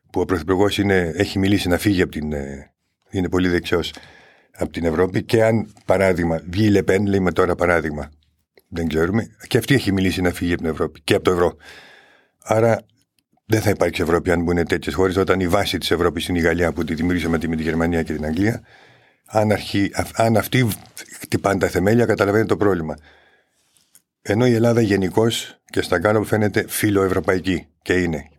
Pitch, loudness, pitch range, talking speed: 95 Hz, -20 LUFS, 85-105 Hz, 180 wpm